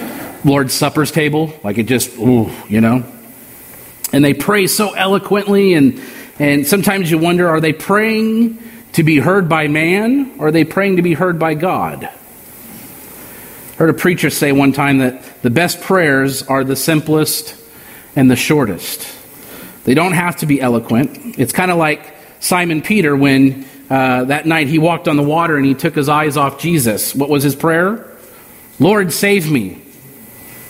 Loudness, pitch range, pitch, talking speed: -13 LUFS, 140-185 Hz, 155 Hz, 170 wpm